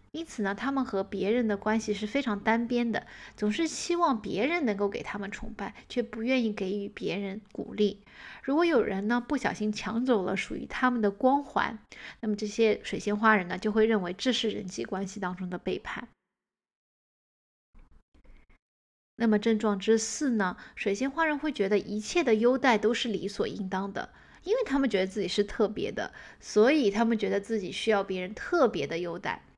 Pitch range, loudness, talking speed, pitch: 200-240 Hz, -29 LUFS, 280 characters per minute, 215 Hz